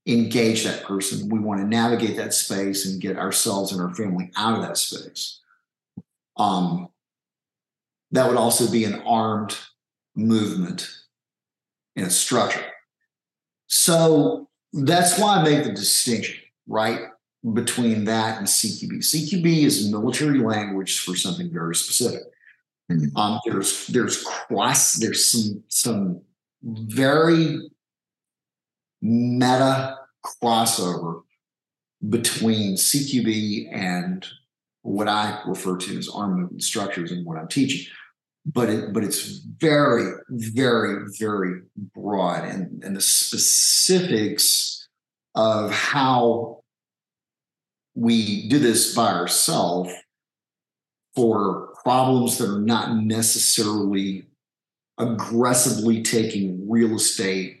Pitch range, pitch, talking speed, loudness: 100-130 Hz, 110 Hz, 110 wpm, -21 LUFS